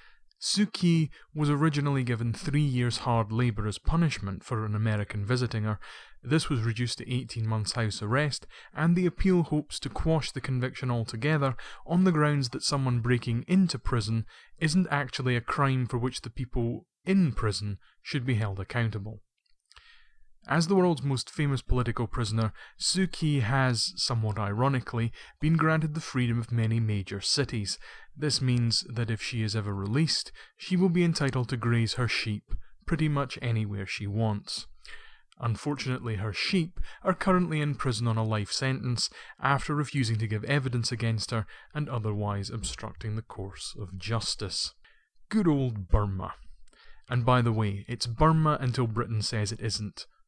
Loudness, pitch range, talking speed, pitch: -29 LUFS, 110-150 Hz, 160 wpm, 125 Hz